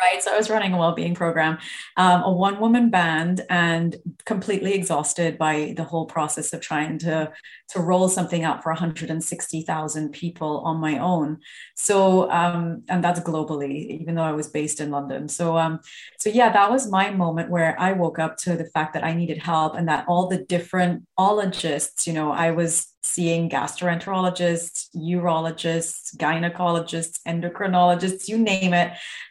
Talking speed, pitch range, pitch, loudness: 165 wpm, 160-180 Hz, 170 Hz, -22 LUFS